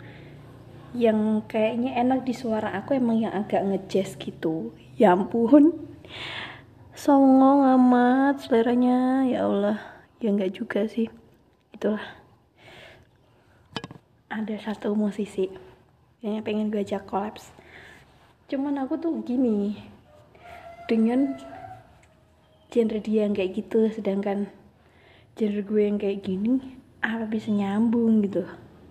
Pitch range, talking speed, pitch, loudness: 200-250 Hz, 105 wpm, 220 Hz, -24 LUFS